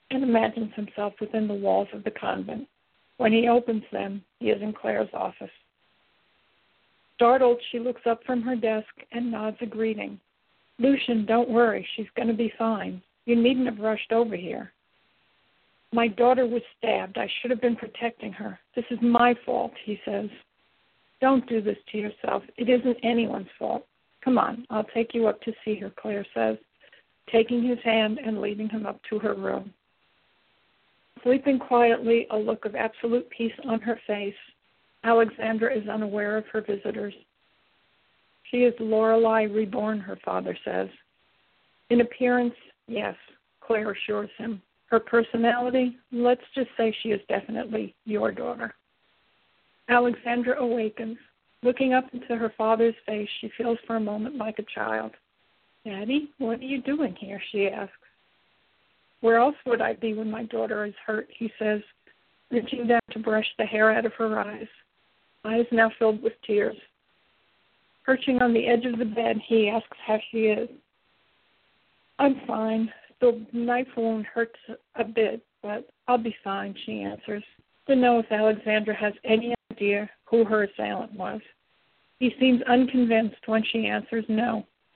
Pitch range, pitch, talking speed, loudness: 215-240 Hz, 225 Hz, 155 wpm, -26 LUFS